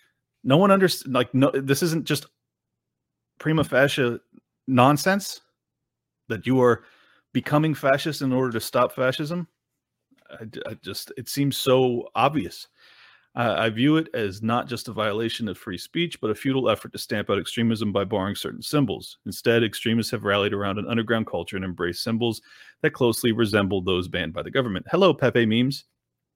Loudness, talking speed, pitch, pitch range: -23 LUFS, 170 wpm, 120 Hz, 110-140 Hz